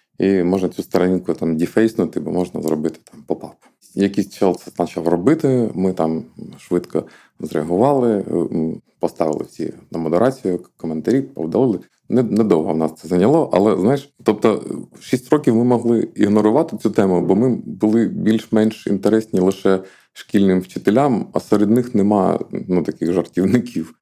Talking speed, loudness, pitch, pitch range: 140 wpm, -18 LUFS, 95 Hz, 90-110 Hz